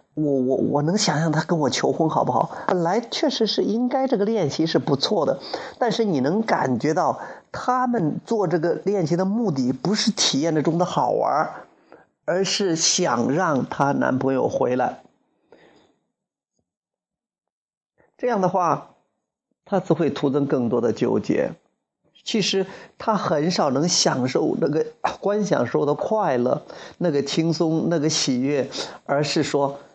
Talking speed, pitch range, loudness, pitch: 210 characters per minute, 150-210 Hz, -22 LUFS, 170 Hz